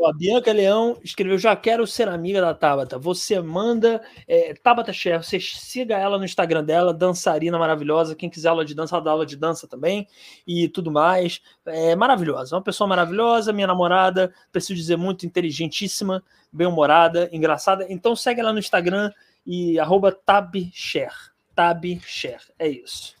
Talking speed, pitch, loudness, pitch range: 160 wpm, 180 Hz, -21 LUFS, 165-205 Hz